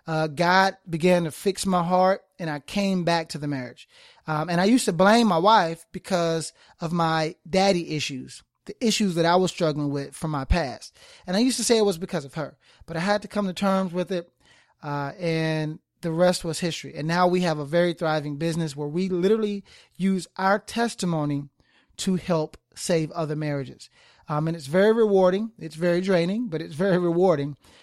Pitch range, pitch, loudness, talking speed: 155-190 Hz, 175 Hz, -24 LUFS, 200 wpm